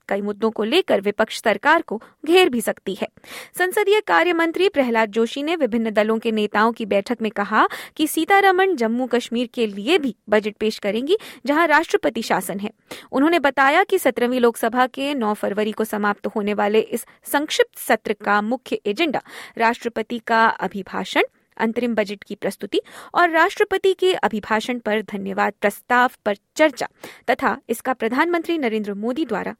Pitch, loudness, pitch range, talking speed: 235 Hz, -20 LUFS, 215-310 Hz, 160 wpm